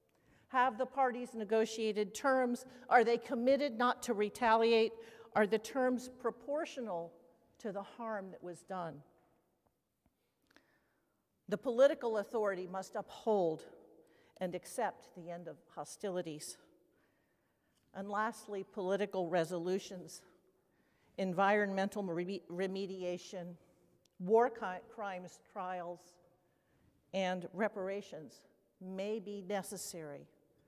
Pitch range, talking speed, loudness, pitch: 180-225 Hz, 95 wpm, -36 LUFS, 200 Hz